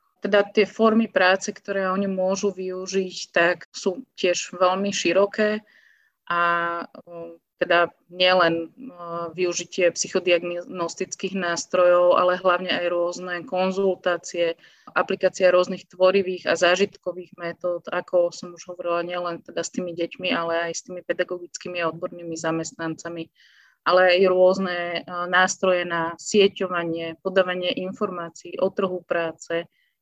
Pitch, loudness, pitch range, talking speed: 180 Hz, -23 LUFS, 170-190 Hz, 115 wpm